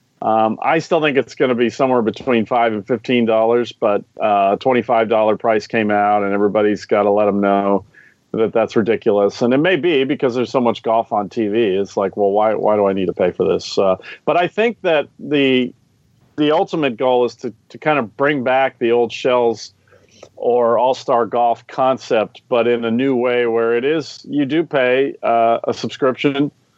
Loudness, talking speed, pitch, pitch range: -17 LUFS, 210 wpm, 120 Hz, 110-135 Hz